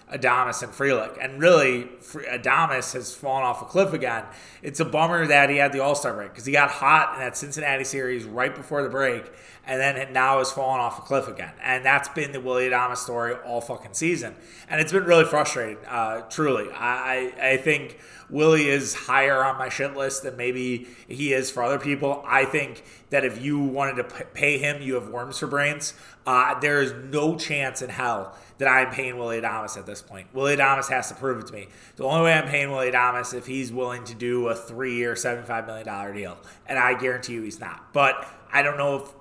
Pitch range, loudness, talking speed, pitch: 120-140 Hz, -23 LUFS, 220 wpm, 130 Hz